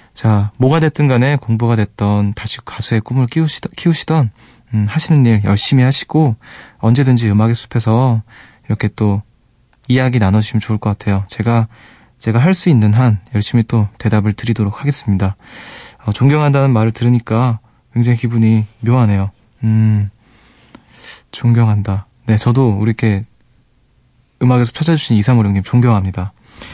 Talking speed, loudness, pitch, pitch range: 325 characters per minute, -14 LUFS, 115 Hz, 110-125 Hz